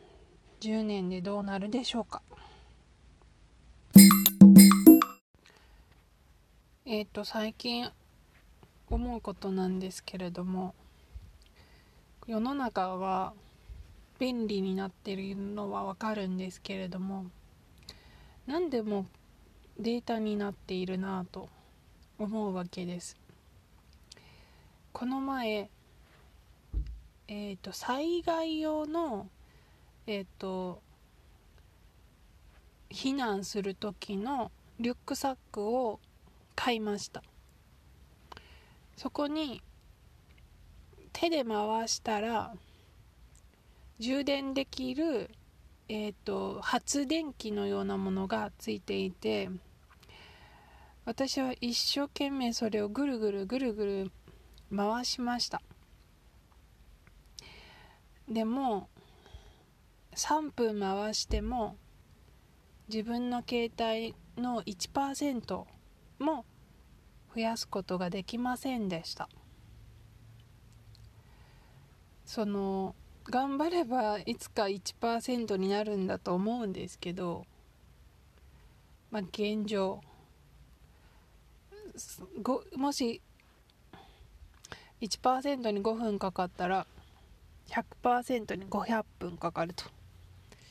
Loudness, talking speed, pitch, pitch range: -30 LUFS, 155 characters per minute, 205 Hz, 185-240 Hz